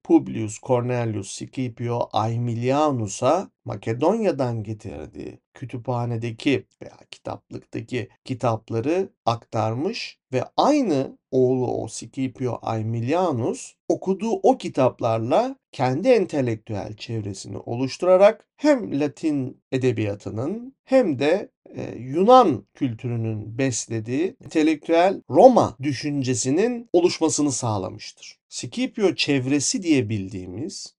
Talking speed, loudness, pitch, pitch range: 80 wpm, -22 LUFS, 130 Hz, 115-165 Hz